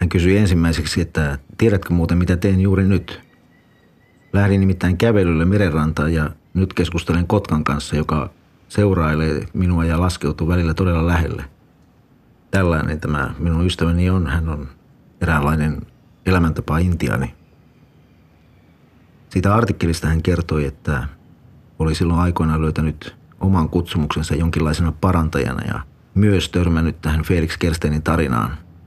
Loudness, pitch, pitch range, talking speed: -19 LUFS, 85 Hz, 80-95 Hz, 120 wpm